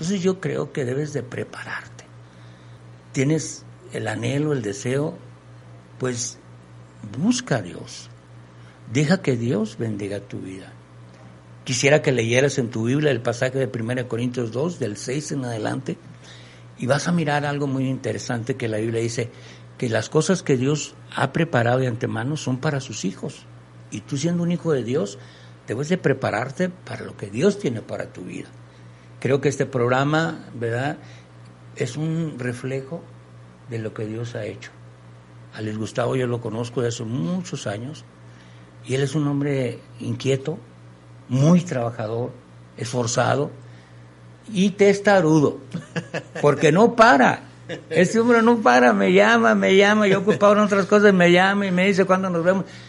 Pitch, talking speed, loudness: 125 Hz, 155 wpm, -21 LUFS